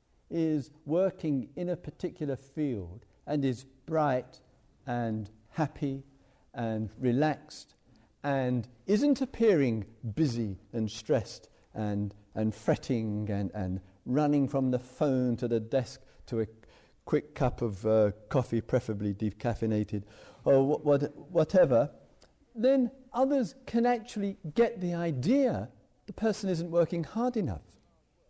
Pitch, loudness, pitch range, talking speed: 135 Hz, -31 LUFS, 110-165 Hz, 120 wpm